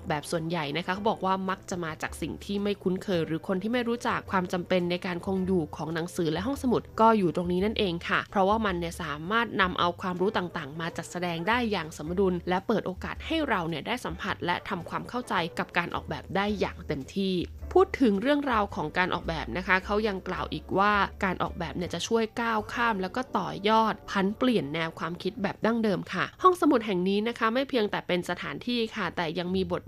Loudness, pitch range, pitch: -28 LUFS, 175-220 Hz, 190 Hz